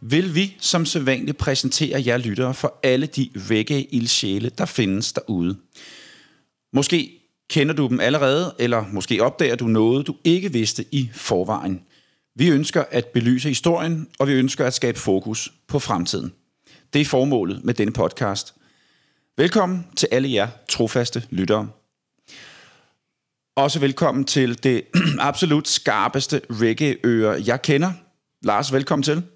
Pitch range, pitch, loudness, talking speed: 120-150 Hz, 135 Hz, -20 LUFS, 135 wpm